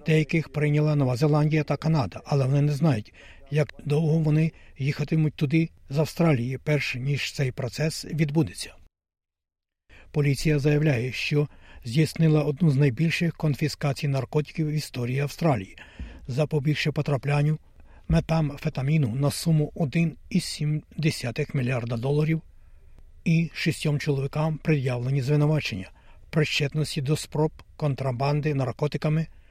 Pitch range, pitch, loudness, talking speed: 135-155 Hz, 150 Hz, -25 LUFS, 110 wpm